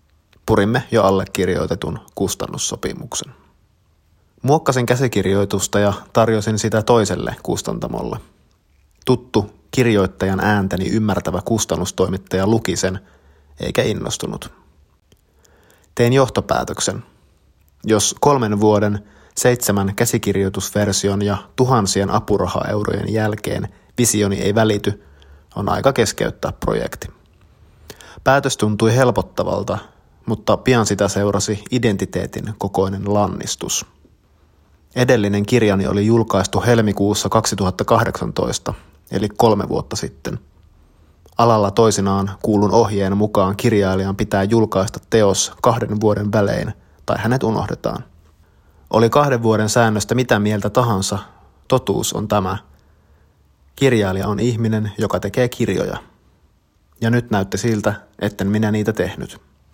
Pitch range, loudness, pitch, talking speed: 95-110 Hz, -18 LUFS, 100 Hz, 95 wpm